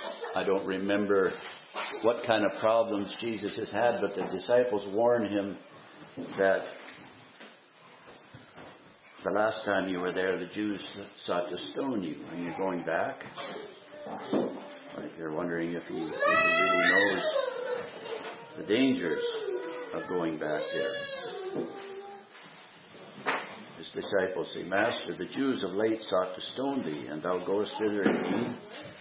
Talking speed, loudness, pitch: 130 wpm, -30 LUFS, 105 Hz